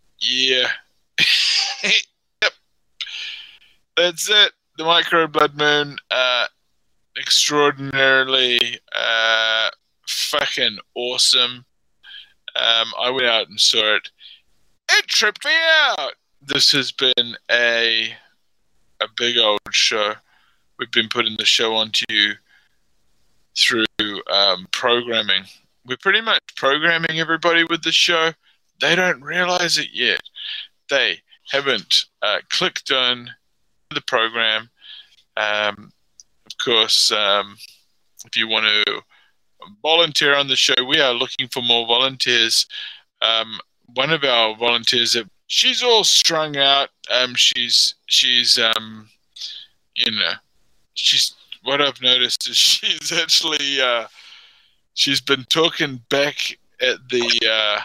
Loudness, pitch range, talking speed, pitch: -17 LUFS, 120-165 Hz, 115 wpm, 130 Hz